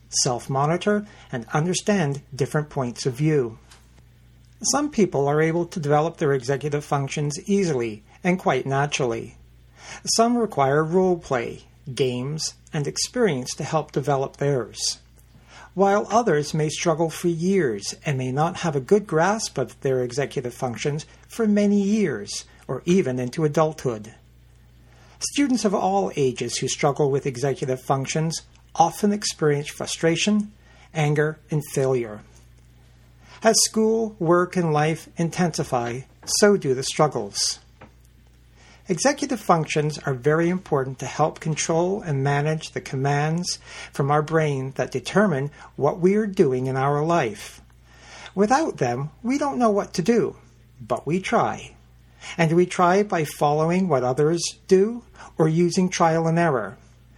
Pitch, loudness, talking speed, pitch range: 150 Hz, -23 LUFS, 135 wpm, 130-180 Hz